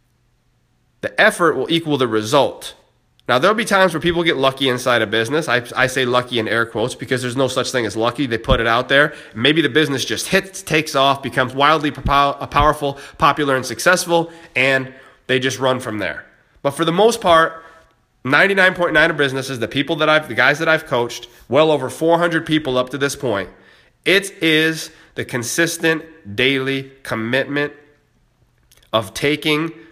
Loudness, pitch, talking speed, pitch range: -17 LUFS, 140 Hz, 180 wpm, 125-160 Hz